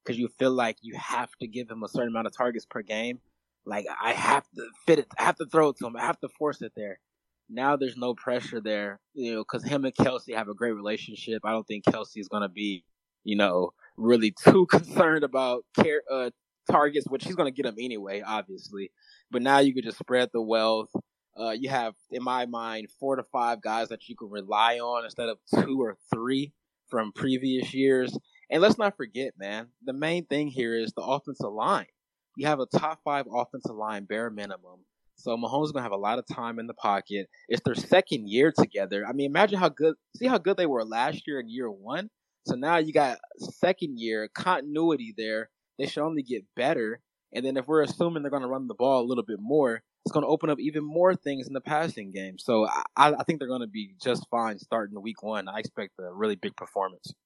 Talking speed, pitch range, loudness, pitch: 230 wpm, 110-145 Hz, -28 LUFS, 125 Hz